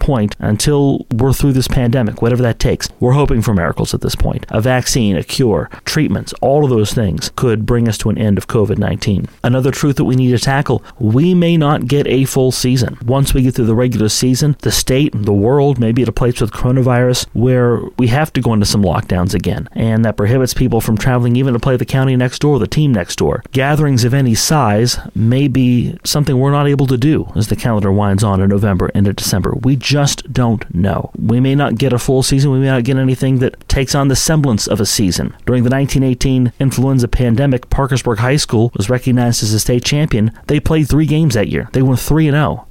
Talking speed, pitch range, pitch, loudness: 230 wpm, 110-135 Hz, 125 Hz, -14 LUFS